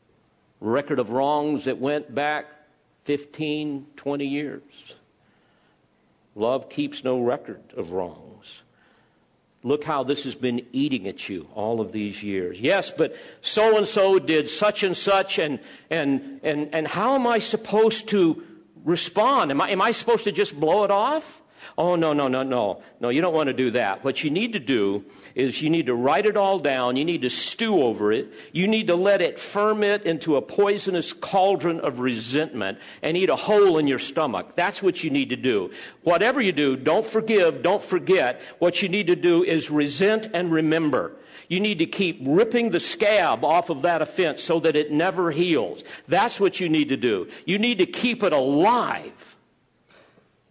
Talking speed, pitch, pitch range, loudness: 180 wpm, 160 Hz, 140-205 Hz, -23 LUFS